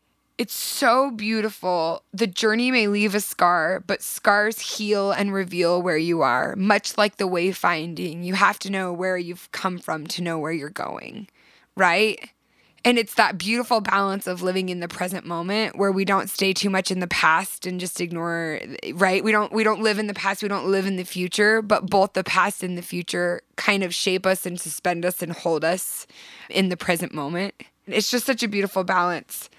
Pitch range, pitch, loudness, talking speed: 175-210 Hz, 190 Hz, -22 LUFS, 205 wpm